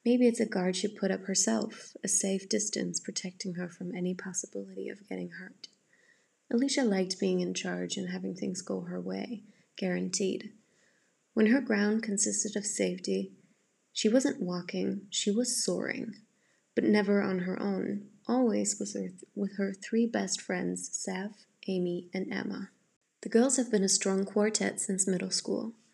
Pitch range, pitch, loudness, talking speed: 180-220 Hz, 195 Hz, -31 LUFS, 165 wpm